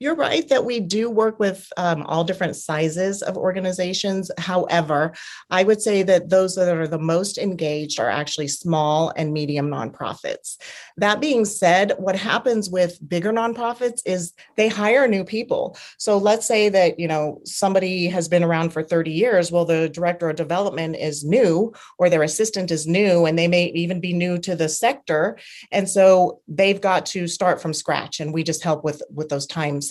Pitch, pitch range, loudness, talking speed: 180 Hz, 160-200 Hz, -21 LUFS, 185 wpm